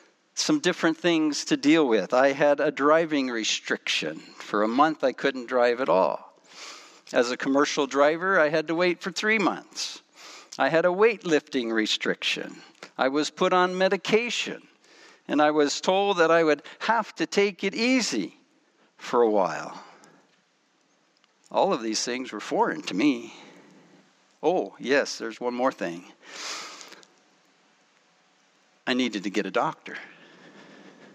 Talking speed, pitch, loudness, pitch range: 145 wpm, 165 Hz, -25 LUFS, 135-205 Hz